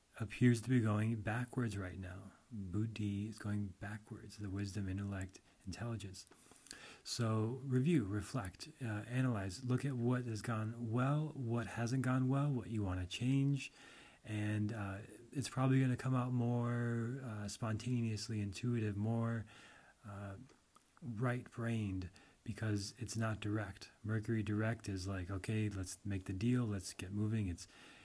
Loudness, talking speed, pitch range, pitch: -40 LUFS, 145 wpm, 100-120 Hz, 110 Hz